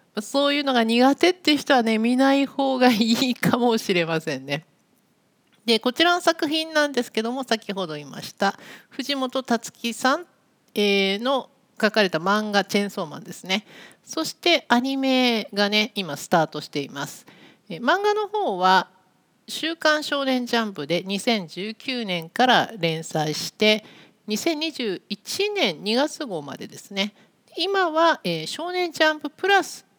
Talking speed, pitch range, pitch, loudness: 270 characters per minute, 195-280 Hz, 230 Hz, -22 LUFS